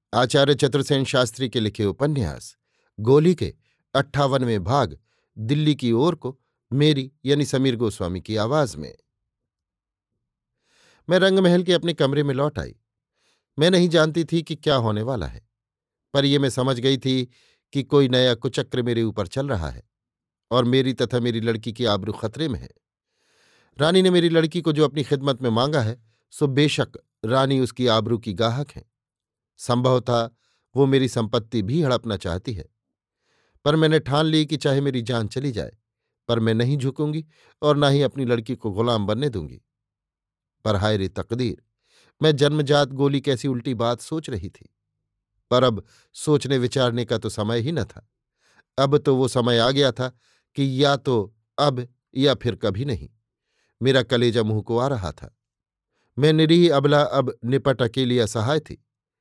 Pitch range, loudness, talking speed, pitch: 115-145 Hz, -22 LUFS, 170 wpm, 130 Hz